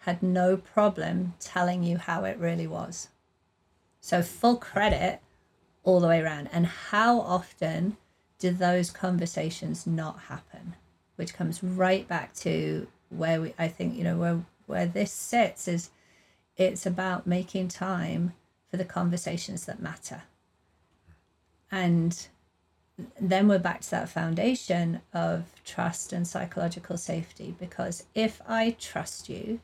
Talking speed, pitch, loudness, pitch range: 135 wpm, 175 Hz, -29 LUFS, 165-185 Hz